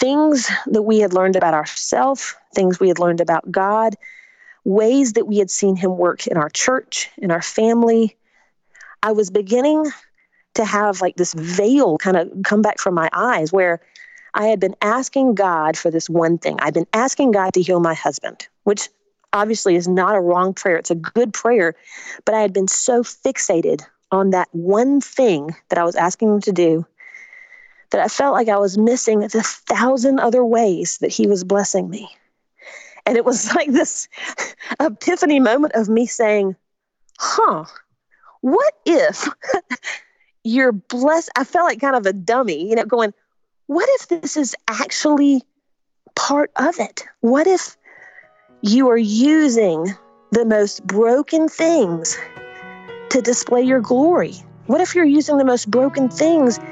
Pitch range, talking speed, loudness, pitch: 190-280 Hz, 165 wpm, -17 LUFS, 225 Hz